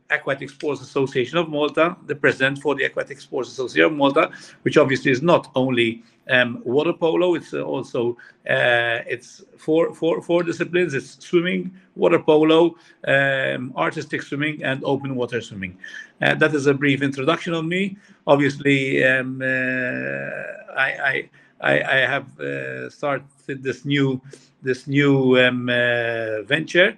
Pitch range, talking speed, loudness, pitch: 125-160 Hz, 145 wpm, -21 LUFS, 140 Hz